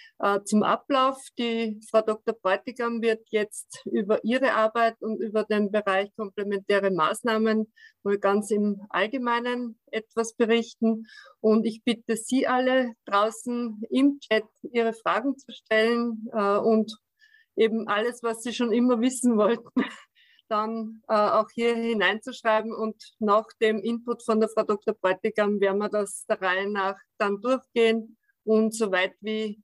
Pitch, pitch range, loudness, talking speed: 220 Hz, 210-240 Hz, -26 LUFS, 140 wpm